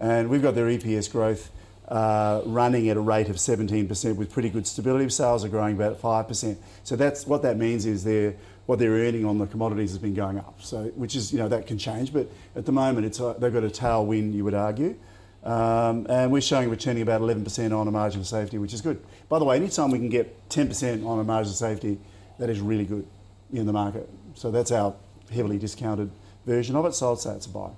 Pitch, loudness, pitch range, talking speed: 110 Hz, -26 LUFS, 105-120 Hz, 240 wpm